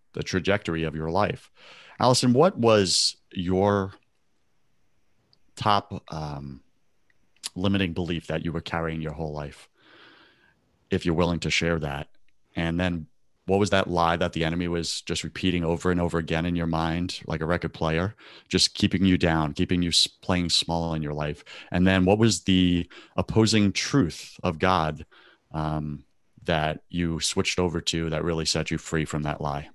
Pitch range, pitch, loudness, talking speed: 80-95 Hz, 85 Hz, -25 LUFS, 165 wpm